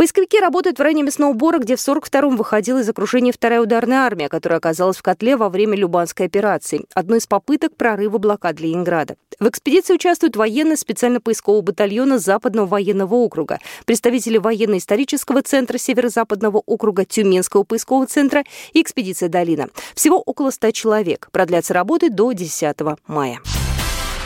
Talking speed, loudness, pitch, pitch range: 145 wpm, -17 LUFS, 225 Hz, 190-265 Hz